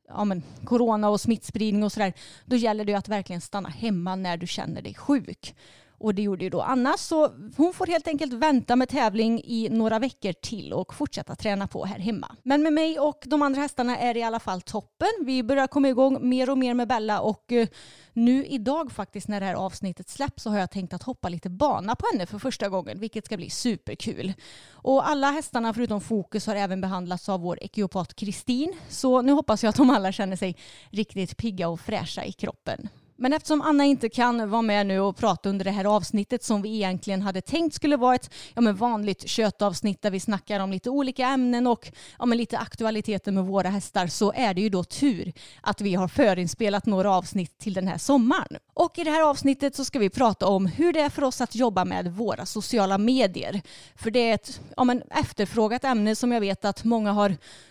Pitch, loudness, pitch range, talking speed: 220 Hz, -25 LUFS, 195-255 Hz, 220 wpm